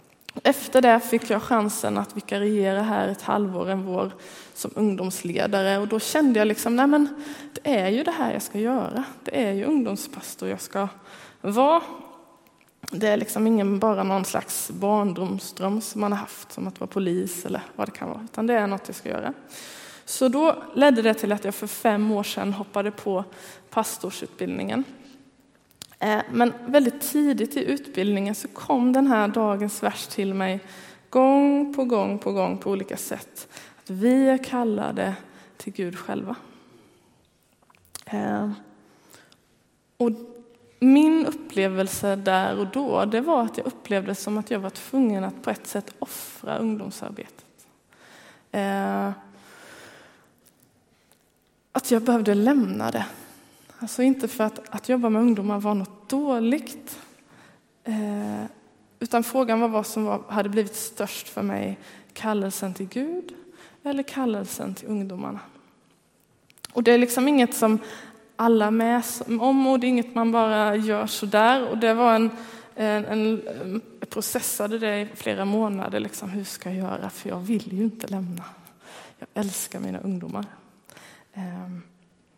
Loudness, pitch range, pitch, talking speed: -24 LUFS, 200-250 Hz, 220 Hz, 150 wpm